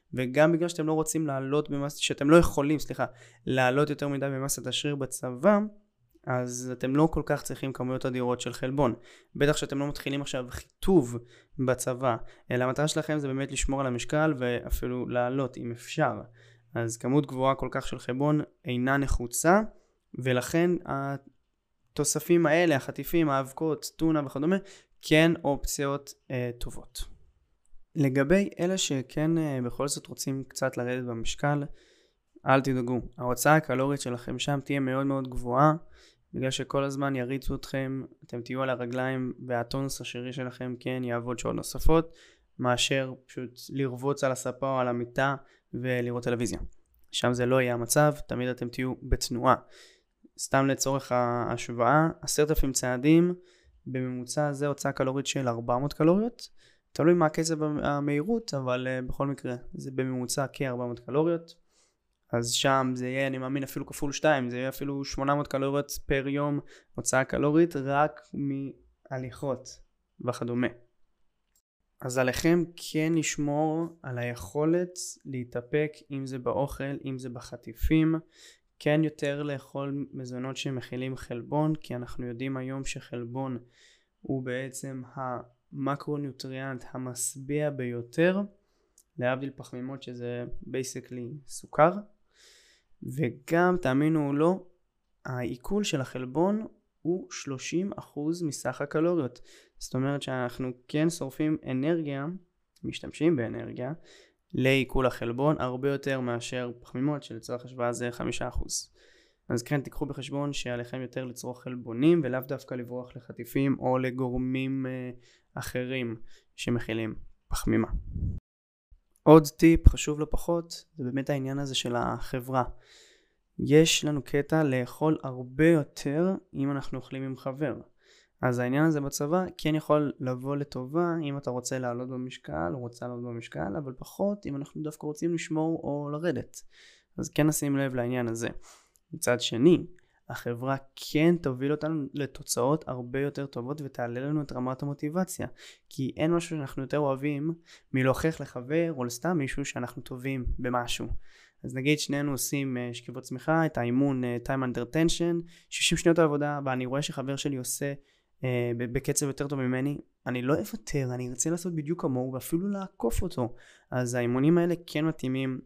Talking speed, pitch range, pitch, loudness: 135 wpm, 125-150 Hz, 135 Hz, -29 LUFS